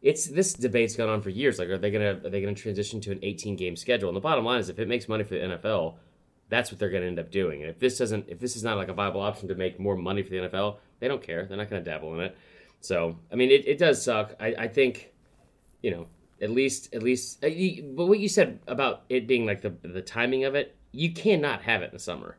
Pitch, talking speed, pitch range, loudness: 110 Hz, 285 wpm, 95-125 Hz, -28 LUFS